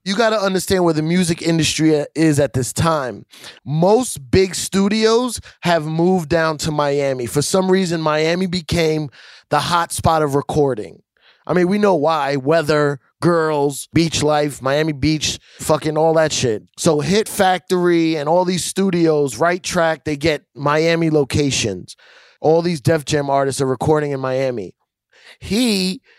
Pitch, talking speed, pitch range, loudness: 160 Hz, 155 wpm, 145-175 Hz, -17 LUFS